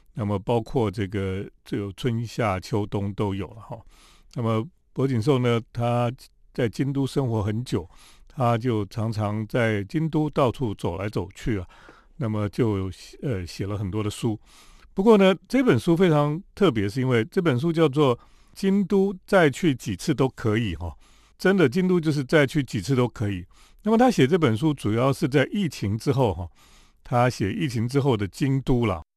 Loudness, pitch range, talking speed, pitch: -24 LUFS, 105-150 Hz, 255 characters per minute, 120 Hz